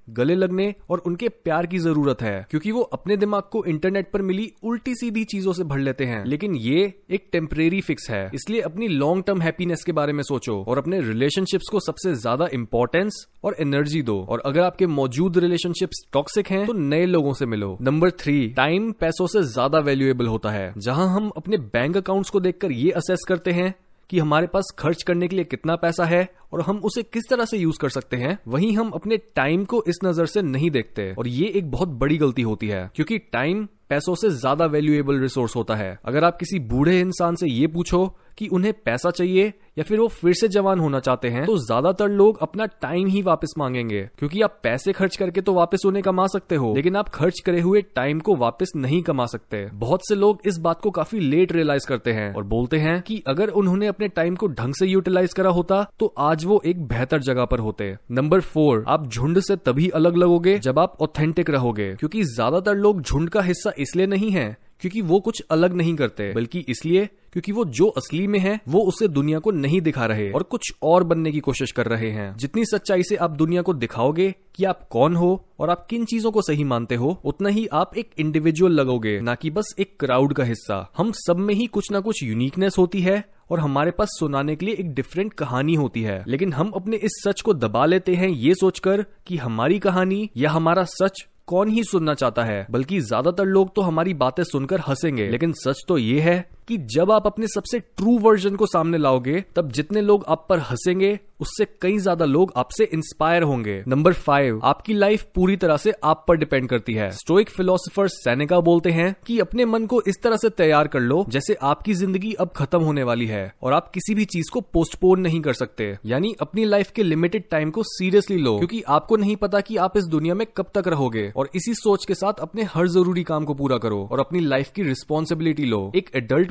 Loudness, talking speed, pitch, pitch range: -21 LUFS, 220 wpm, 175 Hz, 140-195 Hz